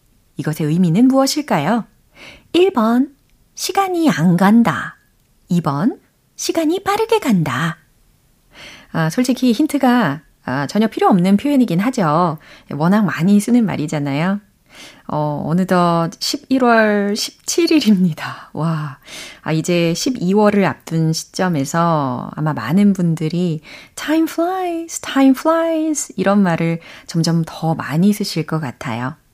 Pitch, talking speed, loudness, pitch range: 190 Hz, 245 characters per minute, -17 LUFS, 160-260 Hz